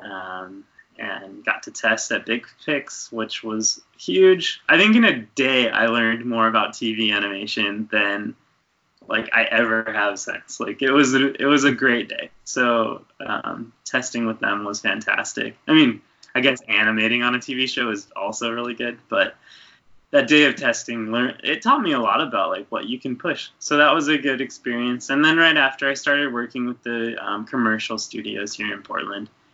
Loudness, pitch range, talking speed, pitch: -20 LUFS, 110-135 Hz, 195 wpm, 120 Hz